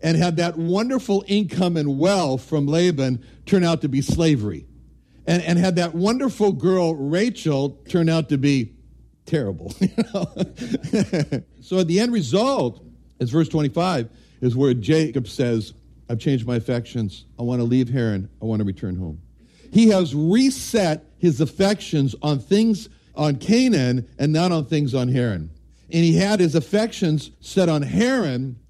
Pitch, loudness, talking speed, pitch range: 155 Hz, -21 LUFS, 160 wpm, 125-185 Hz